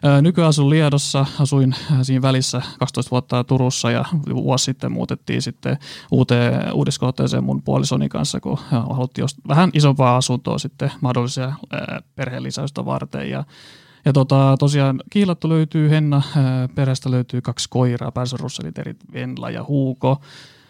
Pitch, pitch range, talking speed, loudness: 130 Hz, 125-145 Hz, 120 wpm, -19 LUFS